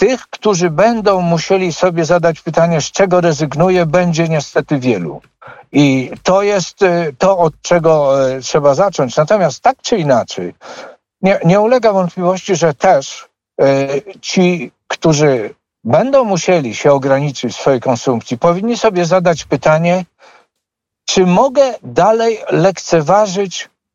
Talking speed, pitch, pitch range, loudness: 125 wpm, 175 Hz, 150-190 Hz, -13 LUFS